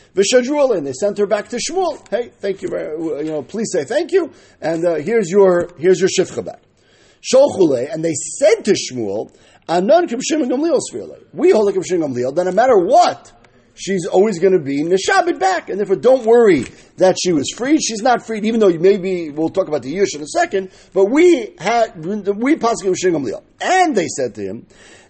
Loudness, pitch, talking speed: -16 LUFS, 220 Hz, 185 wpm